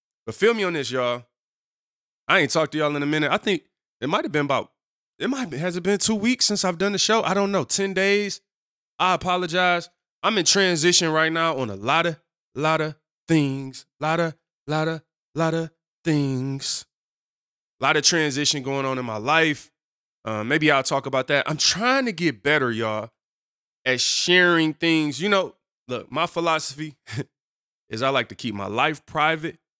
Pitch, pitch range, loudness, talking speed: 160 Hz, 135-180 Hz, -22 LUFS, 190 wpm